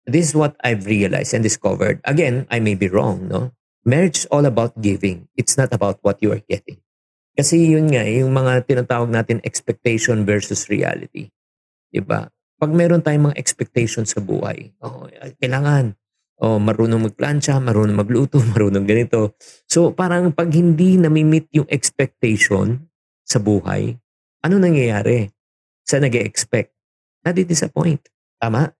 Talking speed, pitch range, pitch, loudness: 140 wpm, 110-155 Hz, 125 Hz, -18 LUFS